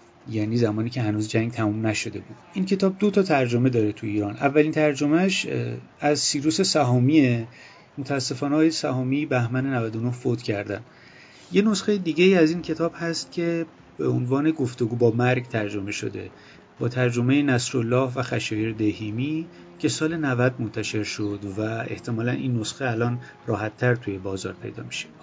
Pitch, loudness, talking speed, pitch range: 125 Hz, -24 LUFS, 150 wpm, 110-150 Hz